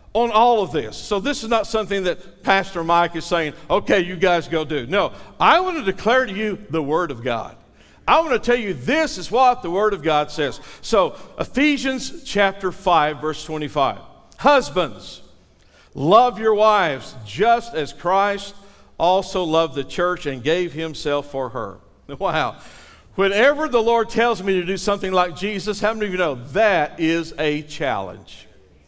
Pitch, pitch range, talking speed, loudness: 190 Hz, 160-220 Hz, 175 wpm, -20 LUFS